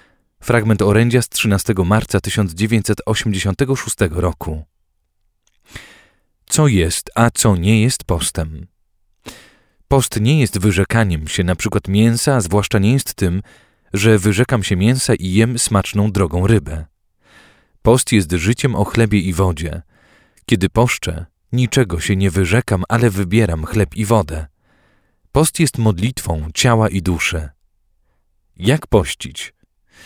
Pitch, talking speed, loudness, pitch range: 105 Hz, 125 wpm, -16 LUFS, 90-115 Hz